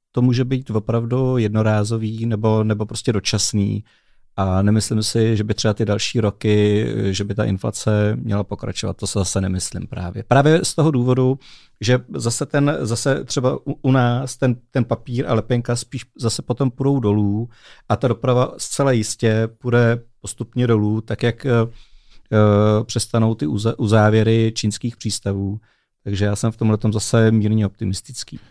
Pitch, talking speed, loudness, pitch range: 115 Hz, 160 wpm, -19 LUFS, 105-125 Hz